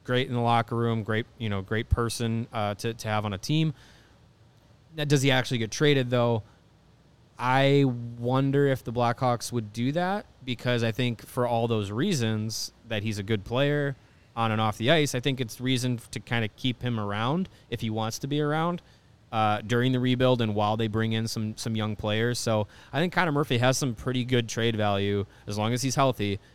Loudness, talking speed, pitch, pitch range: -27 LUFS, 215 wpm, 120 Hz, 110-130 Hz